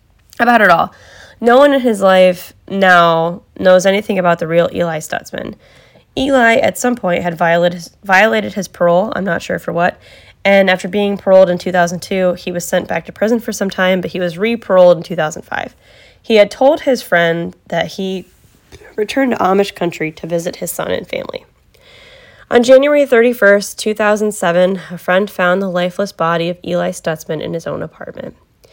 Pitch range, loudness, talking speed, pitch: 175-215 Hz, -13 LUFS, 175 wpm, 190 Hz